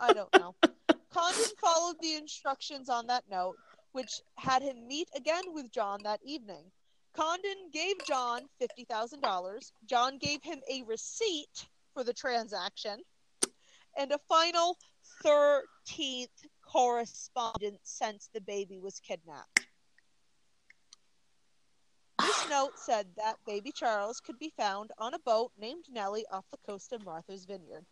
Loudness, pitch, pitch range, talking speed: -33 LUFS, 265 Hz, 220-320 Hz, 130 wpm